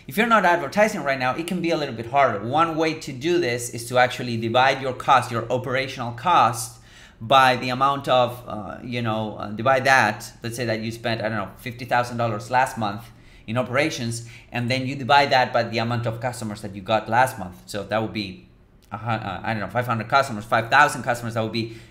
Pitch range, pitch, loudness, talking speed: 110-130 Hz, 120 Hz, -22 LUFS, 230 wpm